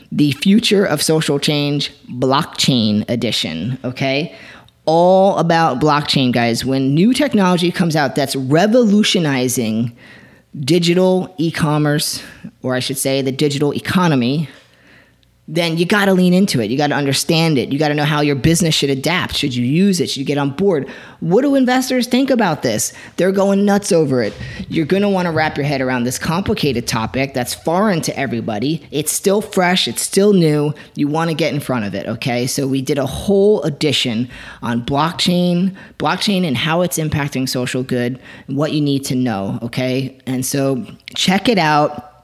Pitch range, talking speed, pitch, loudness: 130-180 Hz, 180 wpm, 150 Hz, -16 LUFS